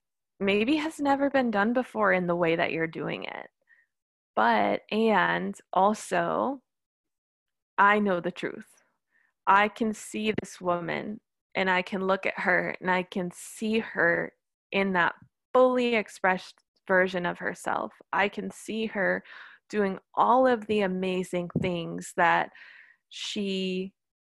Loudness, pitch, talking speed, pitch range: -27 LUFS, 195 Hz, 135 wpm, 185-220 Hz